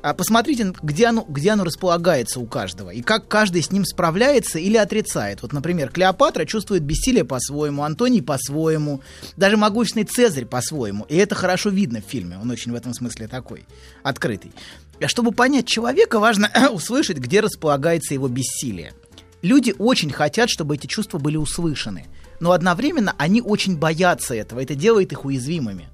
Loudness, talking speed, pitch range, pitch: -20 LUFS, 160 wpm, 130-215 Hz, 170 Hz